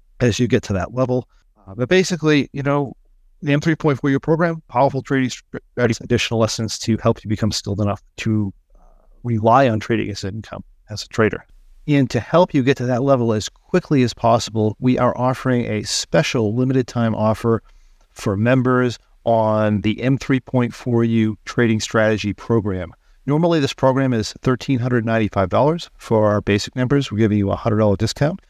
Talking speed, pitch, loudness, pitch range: 160 wpm, 120 Hz, -19 LUFS, 110-135 Hz